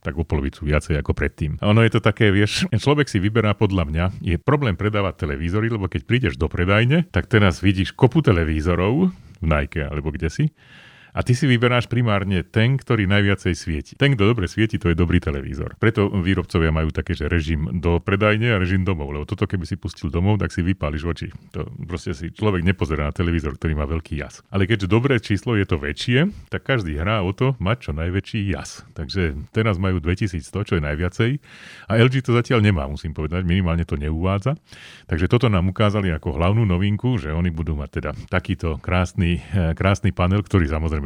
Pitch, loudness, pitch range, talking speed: 95 Hz, -21 LUFS, 85-110 Hz, 200 wpm